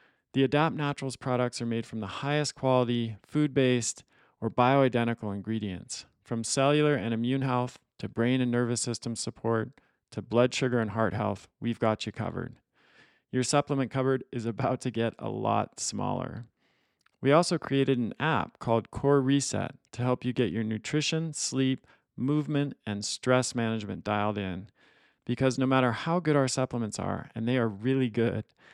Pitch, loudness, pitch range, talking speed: 125 Hz, -29 LUFS, 115-135 Hz, 165 wpm